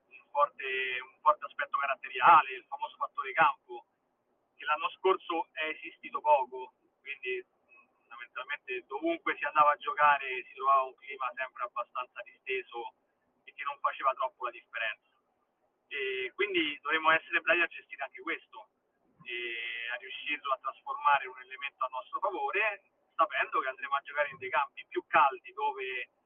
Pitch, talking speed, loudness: 295 Hz, 155 wpm, -31 LUFS